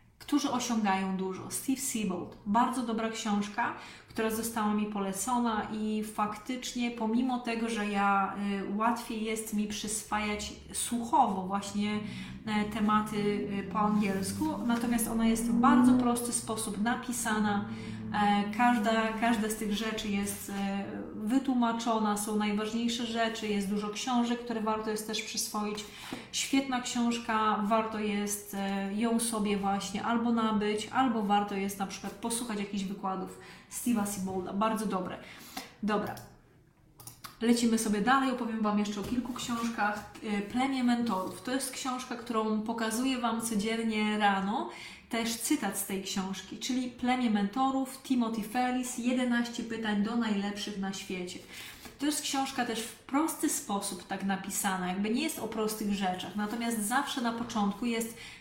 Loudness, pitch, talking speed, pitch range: -31 LUFS, 220 Hz, 135 wpm, 205-240 Hz